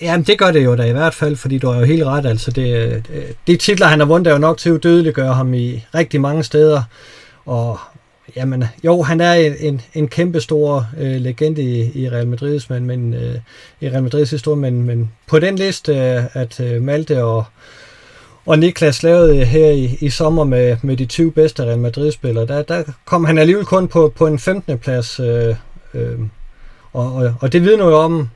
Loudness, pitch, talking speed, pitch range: -15 LUFS, 145 Hz, 205 wpm, 125-160 Hz